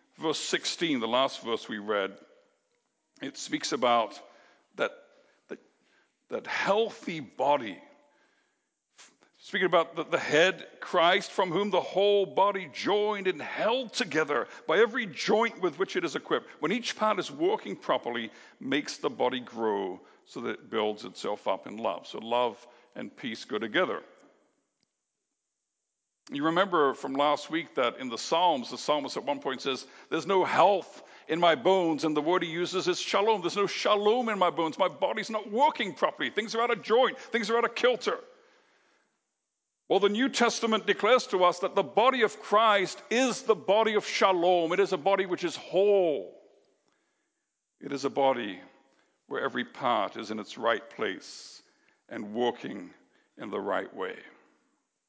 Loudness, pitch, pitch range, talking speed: -28 LUFS, 200 Hz, 175-235 Hz, 165 wpm